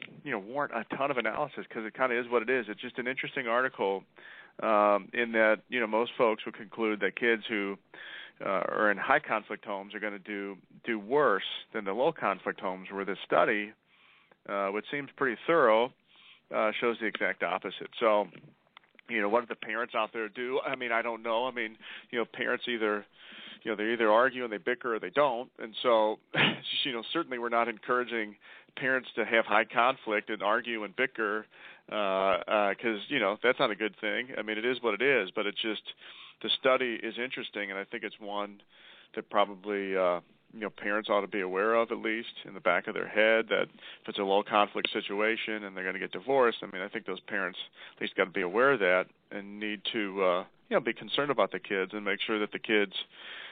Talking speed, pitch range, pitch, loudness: 225 wpm, 100-115 Hz, 110 Hz, -30 LUFS